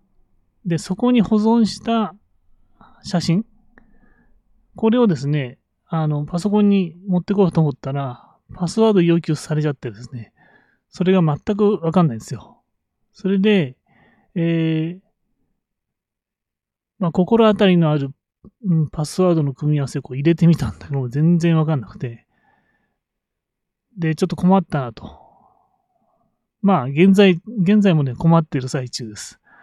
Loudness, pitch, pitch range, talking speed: -18 LUFS, 170 Hz, 145-195 Hz, 280 characters per minute